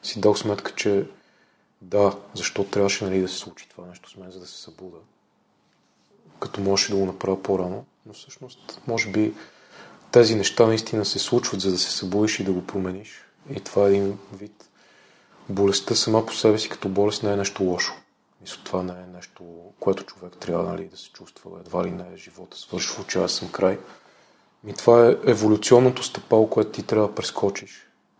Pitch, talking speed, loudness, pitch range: 100 Hz, 195 wpm, -22 LUFS, 95-110 Hz